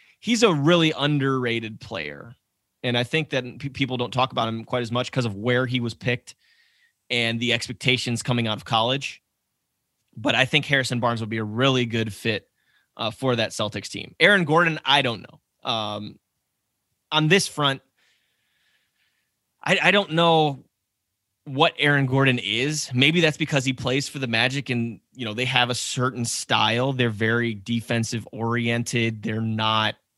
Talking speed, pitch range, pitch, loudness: 170 wpm, 115-140 Hz, 125 Hz, -22 LUFS